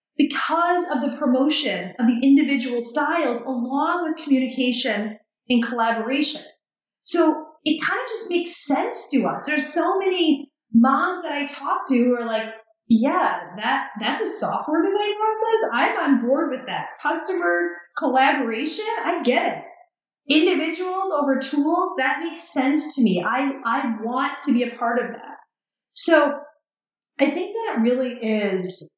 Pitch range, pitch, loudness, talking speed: 245-335 Hz, 285 Hz, -22 LUFS, 155 wpm